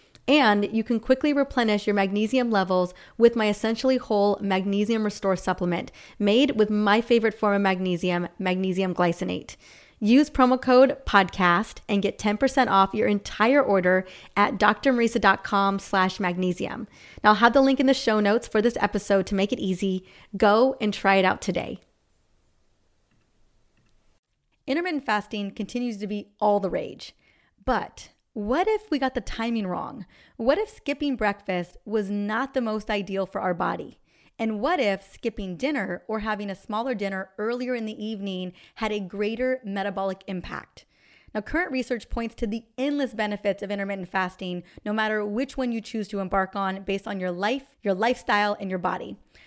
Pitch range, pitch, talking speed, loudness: 195-235 Hz, 210 Hz, 165 wpm, -24 LUFS